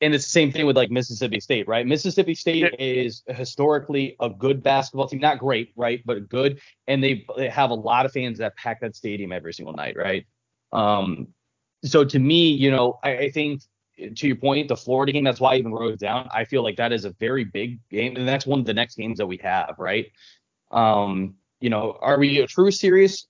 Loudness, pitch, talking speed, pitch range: -22 LUFS, 130 Hz, 225 wpm, 115-140 Hz